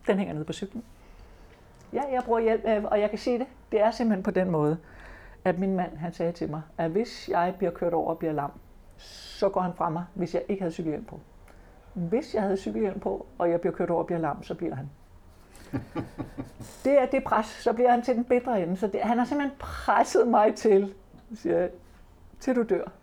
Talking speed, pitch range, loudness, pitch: 225 wpm, 170-220 Hz, -27 LUFS, 190 Hz